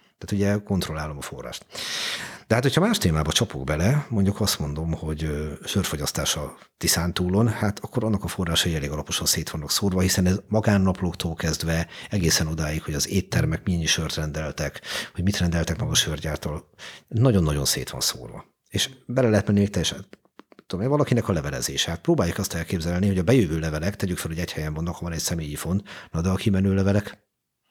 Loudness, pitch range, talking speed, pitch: -24 LUFS, 80-100 Hz, 190 wpm, 90 Hz